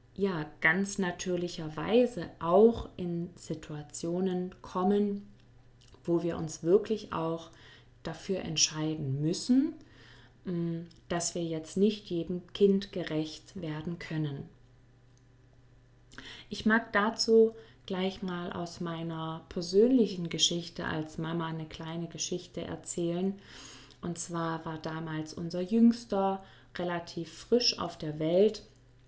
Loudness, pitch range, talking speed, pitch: -30 LUFS, 155-190 Hz, 105 wpm, 170 Hz